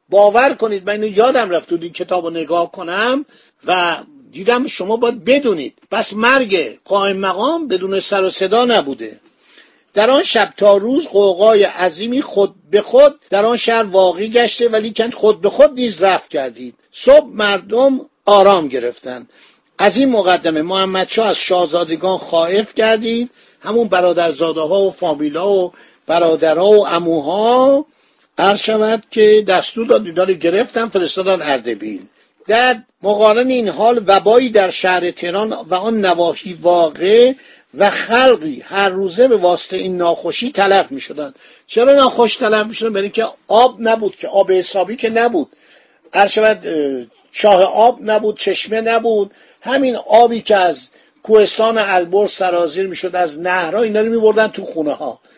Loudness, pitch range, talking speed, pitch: -14 LUFS, 180-230 Hz, 150 wpm, 205 Hz